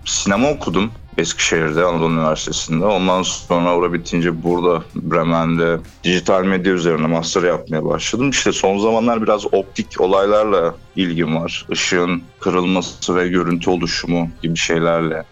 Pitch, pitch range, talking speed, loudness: 85 Hz, 85-95 Hz, 125 wpm, -17 LUFS